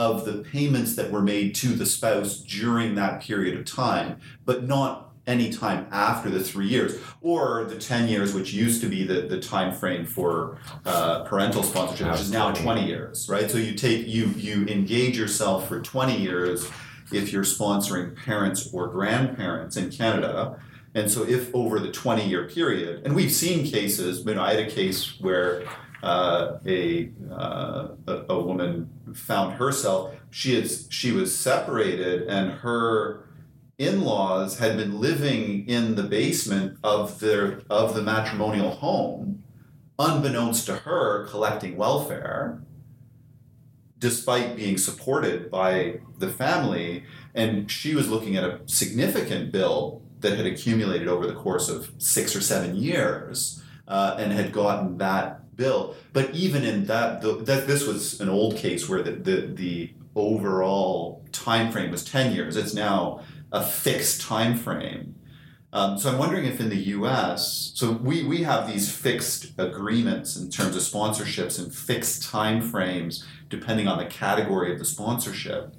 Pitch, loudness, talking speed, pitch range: 110 Hz, -25 LUFS, 160 wpm, 100-125 Hz